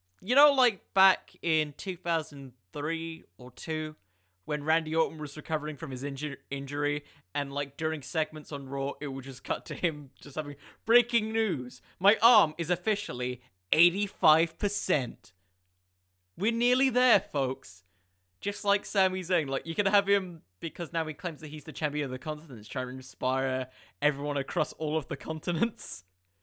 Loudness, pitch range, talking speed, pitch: -29 LUFS, 130-175 Hz, 170 wpm, 155 Hz